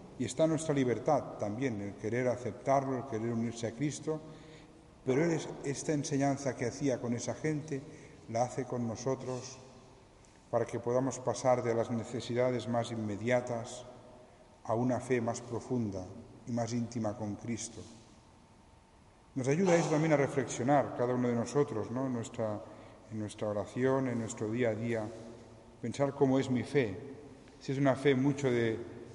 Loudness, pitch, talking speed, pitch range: -34 LUFS, 125 Hz, 160 wpm, 115-135 Hz